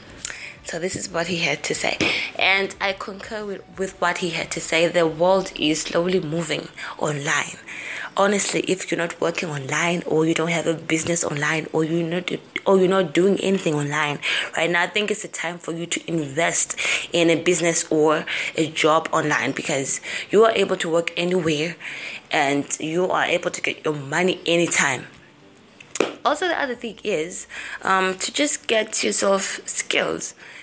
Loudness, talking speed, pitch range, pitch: -21 LUFS, 180 wpm, 160-190 Hz, 170 Hz